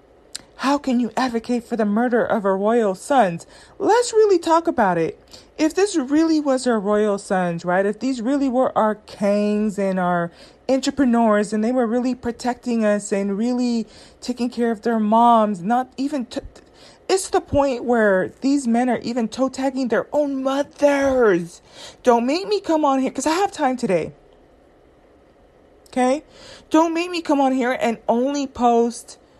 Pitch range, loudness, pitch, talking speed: 220-280 Hz, -20 LUFS, 245 Hz, 170 wpm